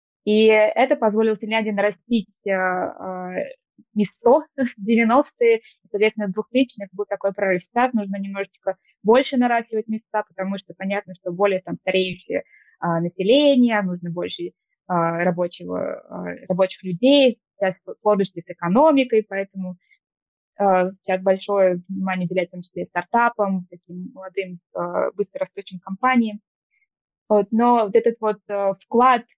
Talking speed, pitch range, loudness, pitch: 130 wpm, 185-230 Hz, -21 LUFS, 200 Hz